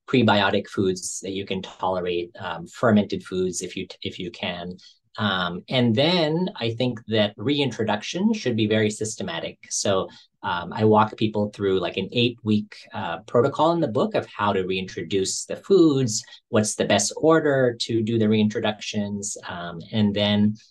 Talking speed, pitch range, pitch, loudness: 165 wpm, 95-120 Hz, 105 Hz, -23 LUFS